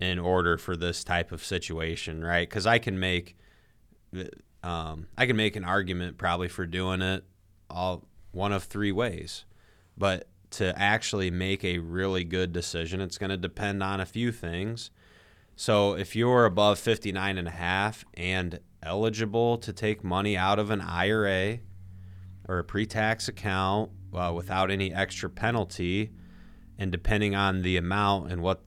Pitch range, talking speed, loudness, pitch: 90-105 Hz, 155 wpm, -28 LUFS, 95 Hz